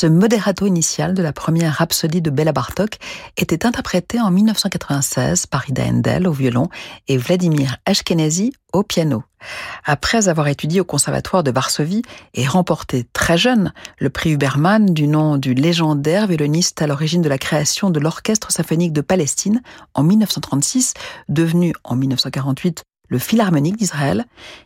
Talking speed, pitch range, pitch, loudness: 150 wpm, 145-195 Hz, 165 Hz, -17 LUFS